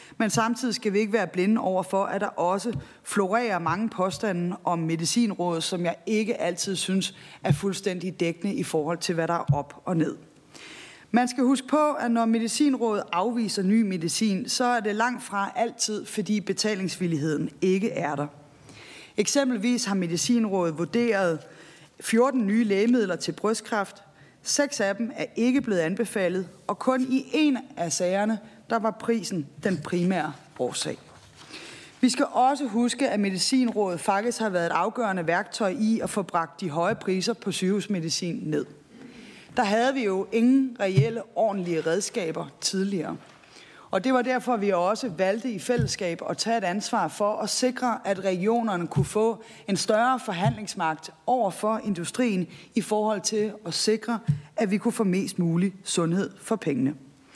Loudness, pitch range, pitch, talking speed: -26 LUFS, 175-230 Hz, 205 Hz, 160 wpm